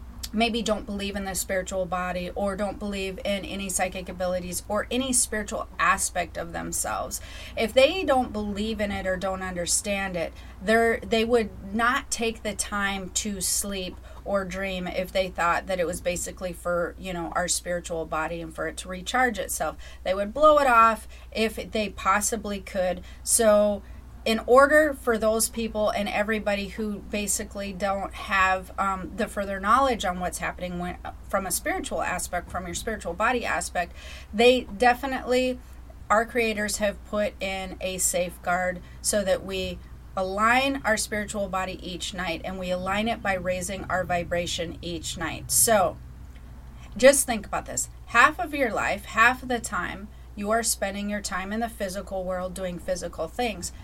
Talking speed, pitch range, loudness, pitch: 170 wpm, 185-225 Hz, -25 LUFS, 200 Hz